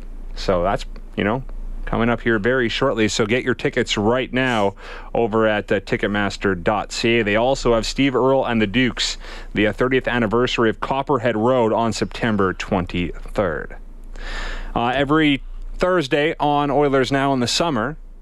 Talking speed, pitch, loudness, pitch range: 150 wpm, 120 Hz, -20 LUFS, 110-135 Hz